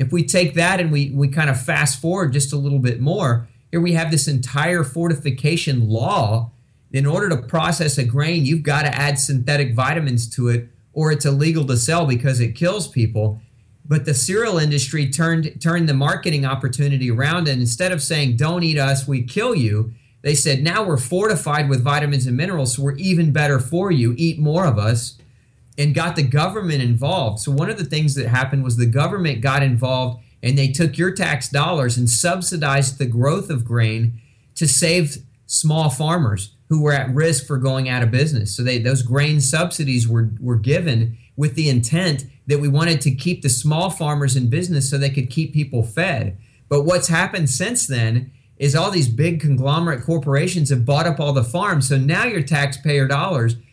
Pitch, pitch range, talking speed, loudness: 140 Hz, 125-160 Hz, 195 wpm, -18 LUFS